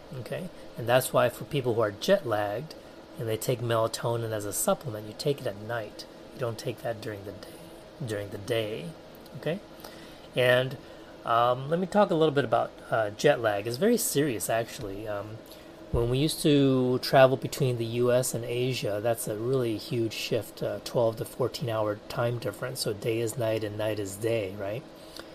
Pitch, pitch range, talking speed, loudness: 120 Hz, 110-135 Hz, 185 wpm, -28 LUFS